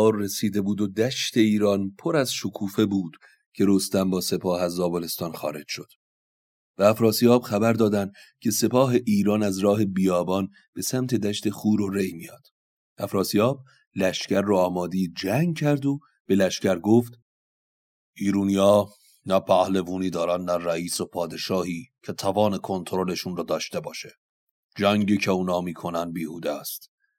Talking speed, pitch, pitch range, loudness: 140 wpm, 100 Hz, 95-110 Hz, -24 LUFS